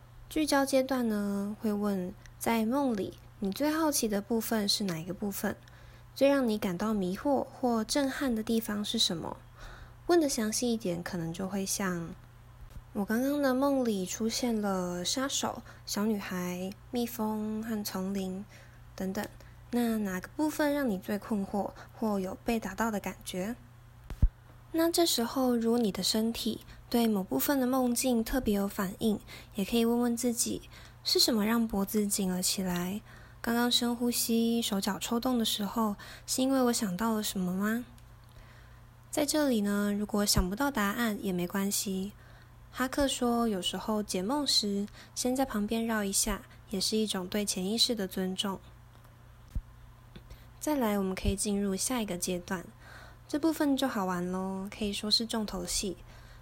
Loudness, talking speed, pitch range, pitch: -31 LUFS, 230 characters per minute, 185-235 Hz, 210 Hz